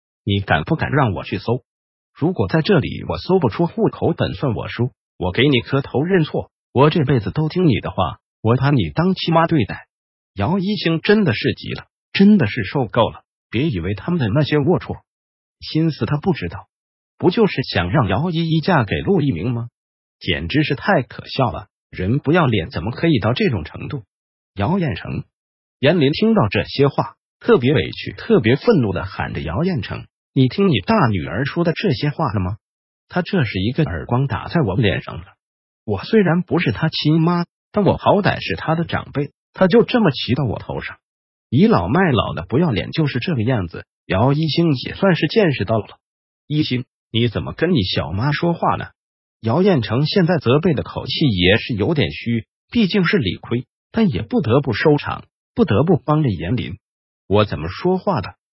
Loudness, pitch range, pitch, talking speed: -18 LUFS, 115-170 Hz, 145 Hz, 270 characters per minute